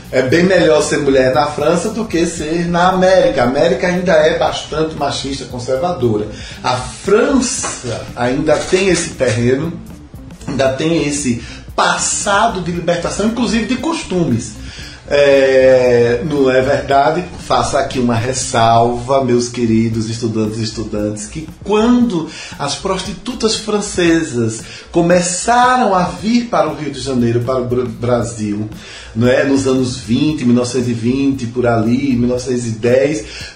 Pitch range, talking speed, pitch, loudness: 120-175 Hz, 130 wpm, 135 Hz, -14 LUFS